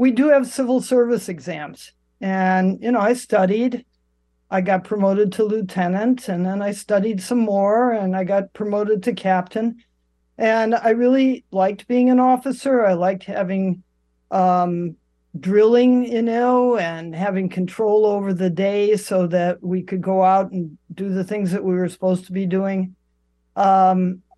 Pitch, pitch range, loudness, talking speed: 195 Hz, 185-225 Hz, -19 LUFS, 160 wpm